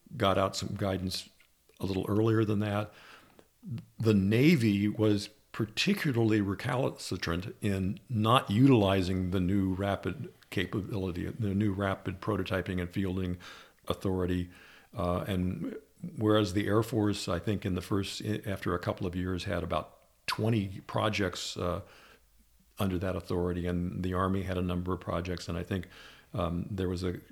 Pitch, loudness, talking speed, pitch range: 95 Hz, -31 LUFS, 145 wpm, 90-105 Hz